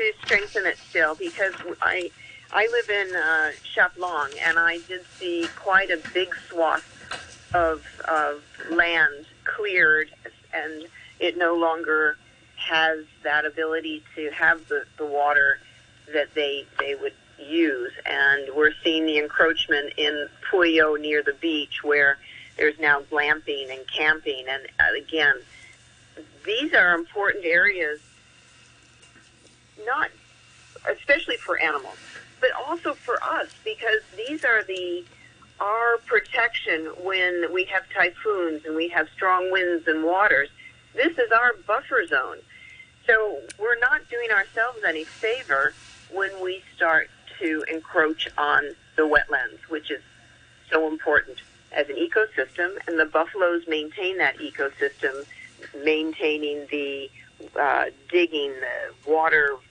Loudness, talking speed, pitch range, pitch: -23 LUFS, 125 wpm, 150-245 Hz, 170 Hz